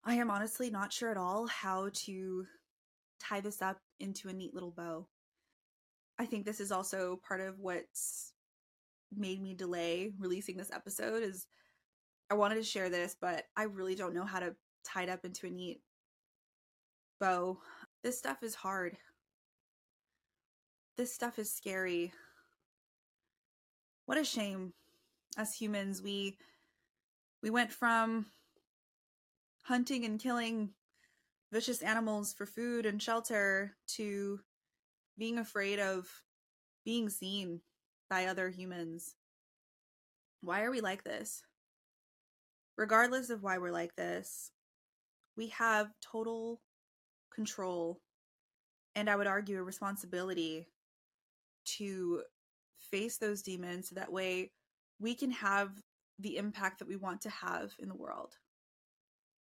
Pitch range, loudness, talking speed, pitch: 185-225 Hz, -38 LUFS, 130 wpm, 200 Hz